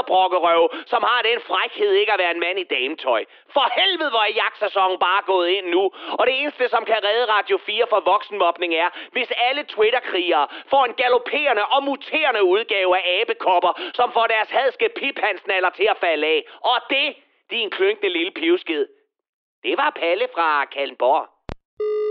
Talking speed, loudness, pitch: 170 wpm, -20 LUFS, 295 Hz